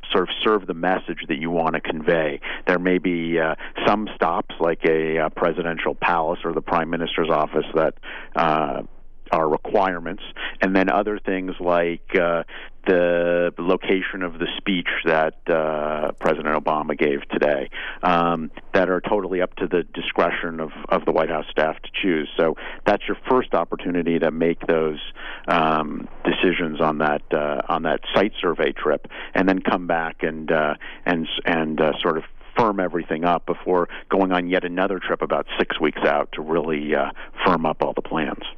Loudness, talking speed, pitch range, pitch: -22 LUFS, 175 wpm, 80-90 Hz, 85 Hz